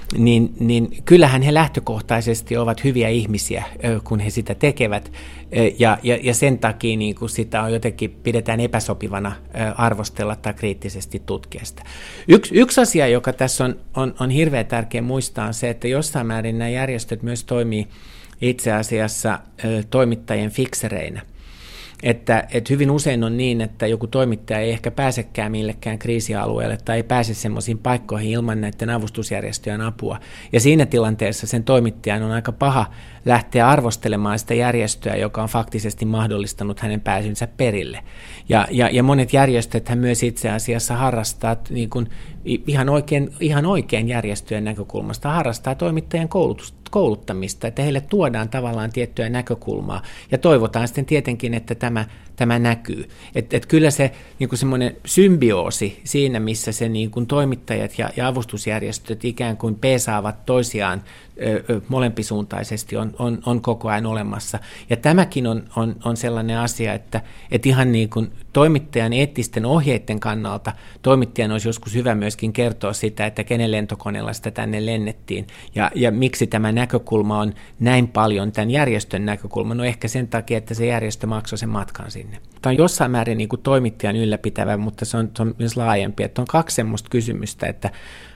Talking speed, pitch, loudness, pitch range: 155 wpm, 115 Hz, -20 LUFS, 110-125 Hz